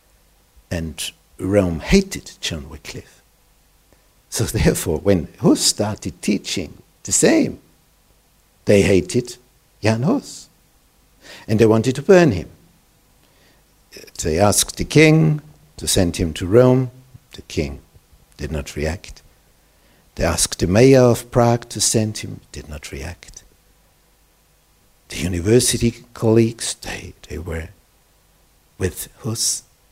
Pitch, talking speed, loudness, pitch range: 105 Hz, 115 wpm, -18 LUFS, 85-125 Hz